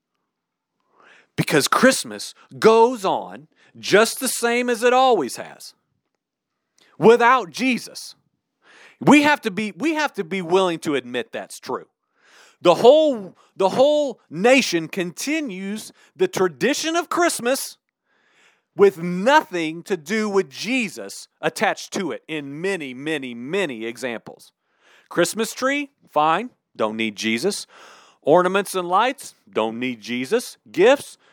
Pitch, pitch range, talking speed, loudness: 200 Hz, 160-255 Hz, 120 wpm, -20 LUFS